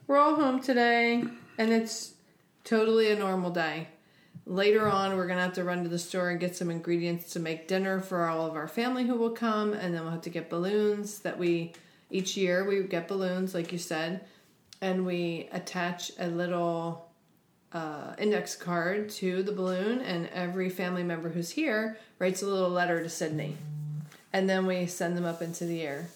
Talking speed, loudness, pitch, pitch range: 195 wpm, -30 LUFS, 180 Hz, 170-200 Hz